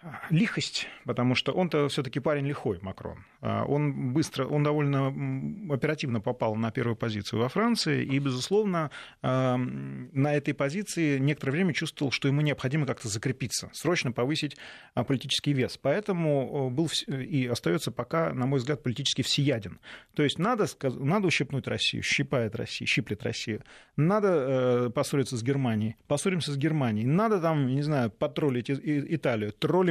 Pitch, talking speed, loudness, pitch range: 140 Hz, 140 wpm, -28 LUFS, 125-155 Hz